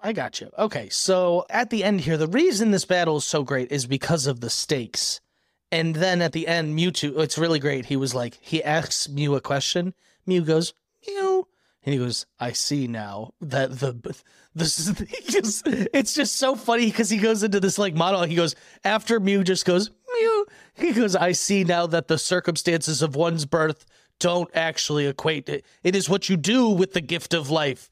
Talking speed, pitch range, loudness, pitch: 205 wpm, 150-200 Hz, -23 LUFS, 170 Hz